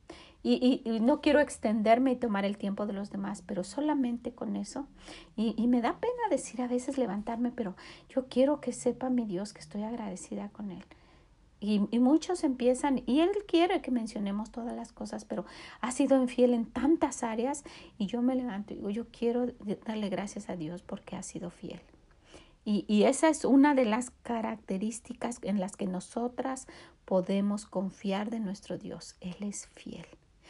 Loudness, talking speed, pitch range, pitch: -31 LUFS, 185 wpm, 200-255 Hz, 235 Hz